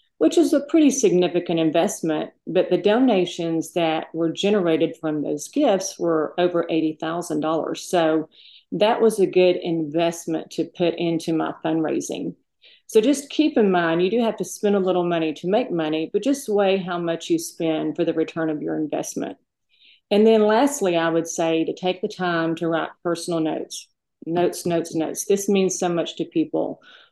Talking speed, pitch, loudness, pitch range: 180 wpm, 170 Hz, -22 LUFS, 160-200 Hz